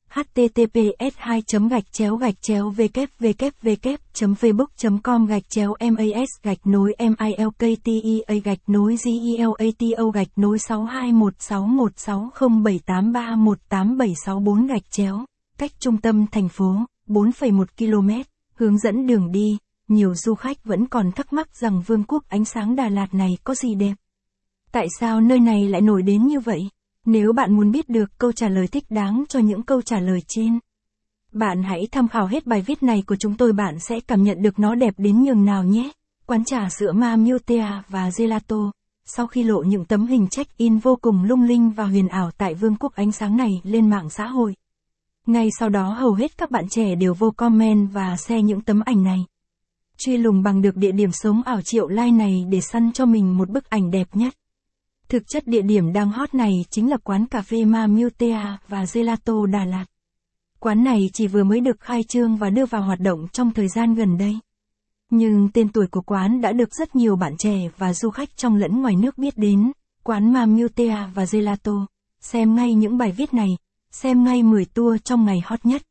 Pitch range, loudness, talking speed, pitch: 200-235 Hz, -20 LUFS, 200 wpm, 220 Hz